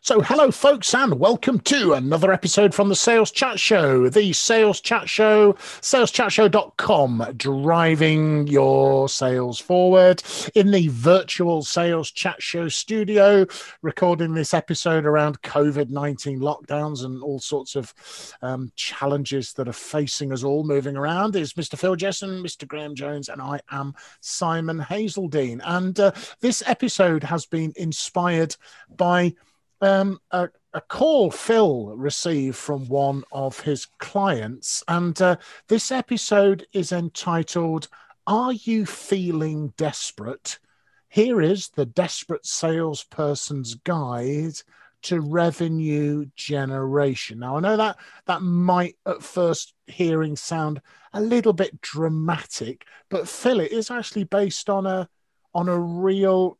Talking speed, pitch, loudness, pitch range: 130 wpm, 165 Hz, -21 LUFS, 145-195 Hz